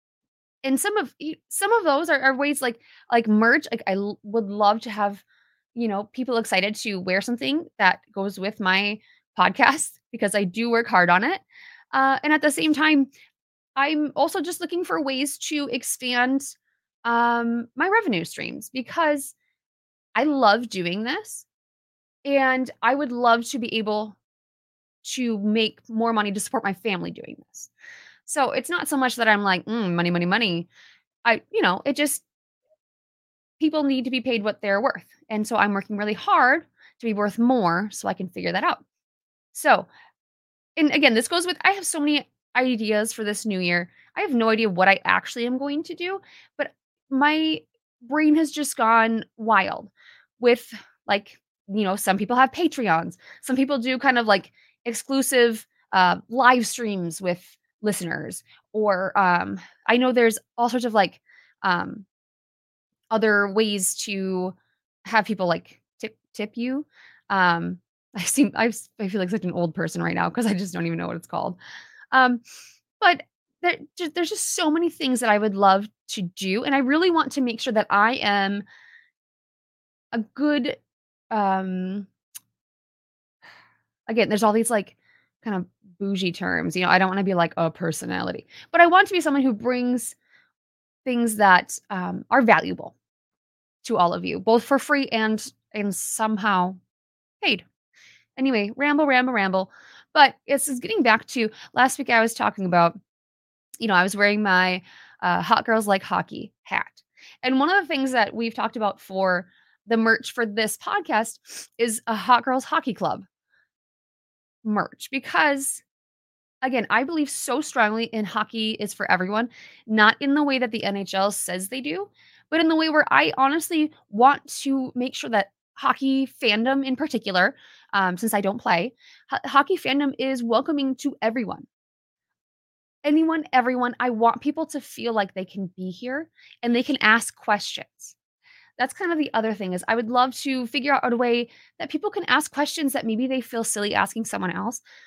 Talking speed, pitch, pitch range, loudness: 175 wpm, 235 Hz, 205-280 Hz, -22 LUFS